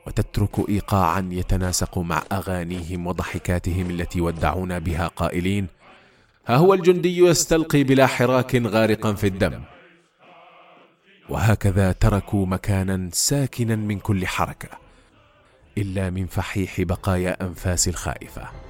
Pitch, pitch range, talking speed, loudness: 100 Hz, 90-125 Hz, 105 wpm, -22 LUFS